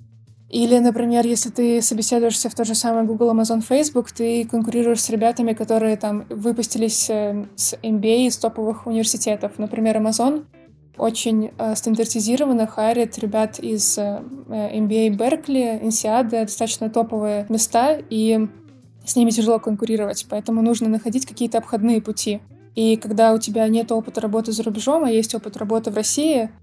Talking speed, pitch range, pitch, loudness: 140 wpm, 220-235 Hz, 225 Hz, -20 LUFS